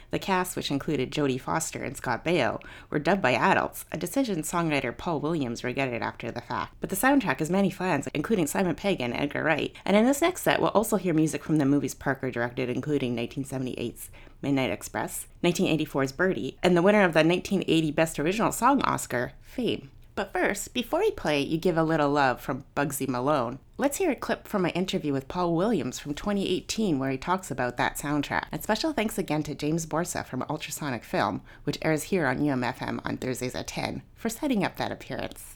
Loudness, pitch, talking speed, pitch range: -27 LUFS, 150 Hz, 205 wpm, 135-185 Hz